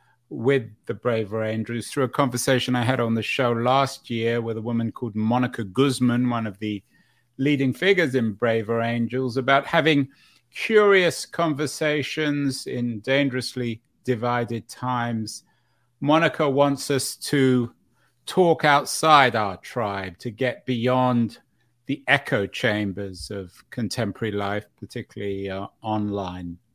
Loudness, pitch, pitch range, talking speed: -23 LUFS, 120 Hz, 110-135 Hz, 125 wpm